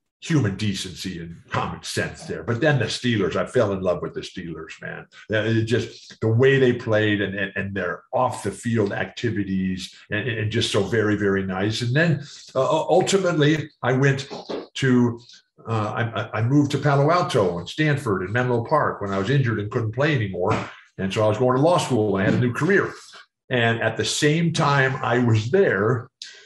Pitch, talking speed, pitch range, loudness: 120 Hz, 195 wpm, 105-140 Hz, -22 LUFS